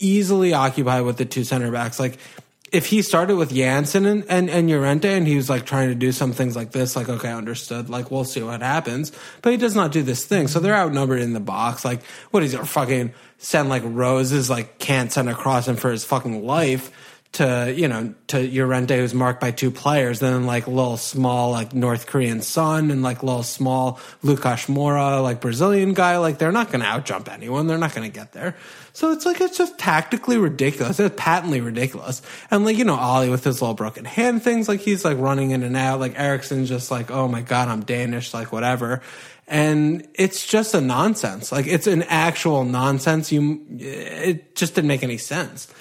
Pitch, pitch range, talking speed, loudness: 135 Hz, 125-165 Hz, 215 wpm, -21 LUFS